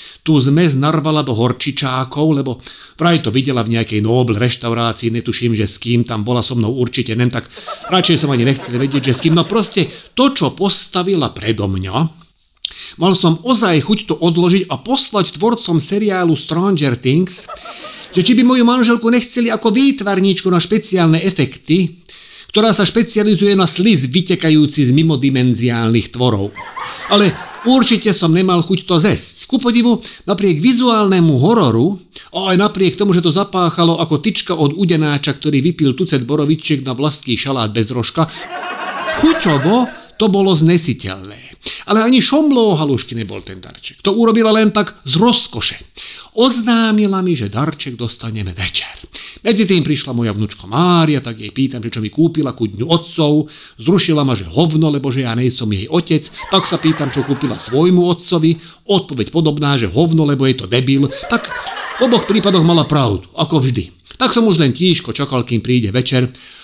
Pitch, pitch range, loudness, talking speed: 160 Hz, 130-195 Hz, -13 LUFS, 165 wpm